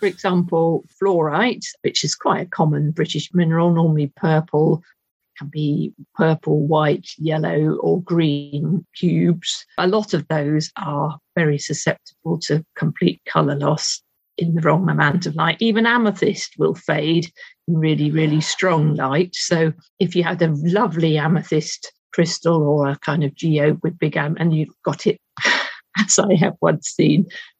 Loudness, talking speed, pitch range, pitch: -19 LUFS, 155 wpm, 155-180 Hz, 165 Hz